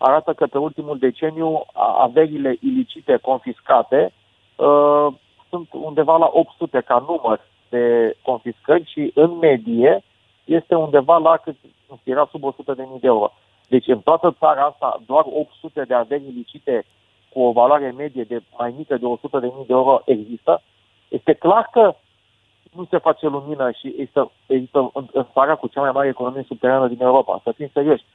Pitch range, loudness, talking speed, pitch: 125-160 Hz, -18 LUFS, 160 wpm, 140 Hz